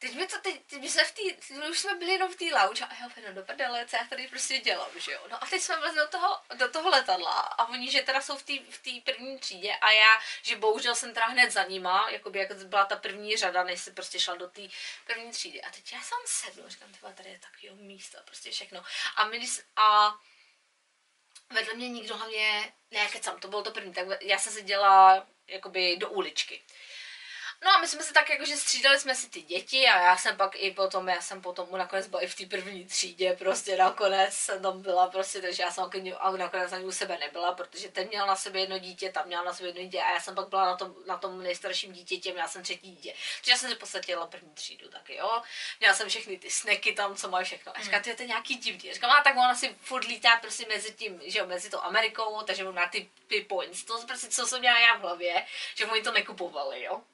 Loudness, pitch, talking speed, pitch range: -27 LUFS, 205 Hz, 235 wpm, 185-250 Hz